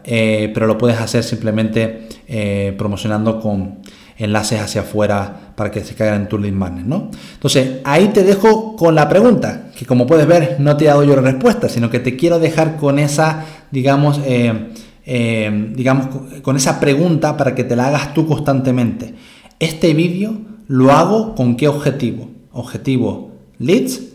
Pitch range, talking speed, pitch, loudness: 110-155 Hz, 170 wpm, 130 Hz, -15 LUFS